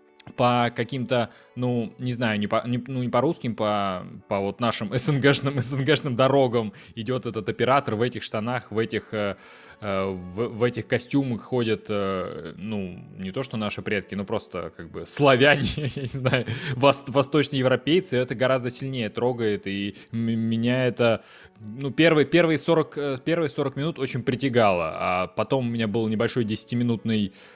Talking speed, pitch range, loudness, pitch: 155 wpm, 110-135 Hz, -24 LUFS, 120 Hz